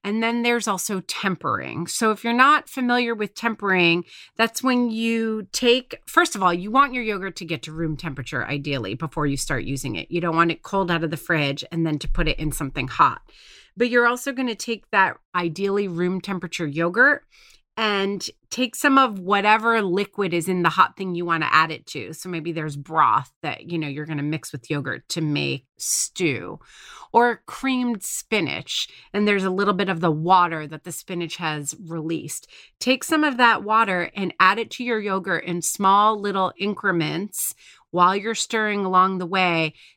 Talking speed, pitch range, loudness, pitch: 195 wpm, 165-225 Hz, -22 LUFS, 185 Hz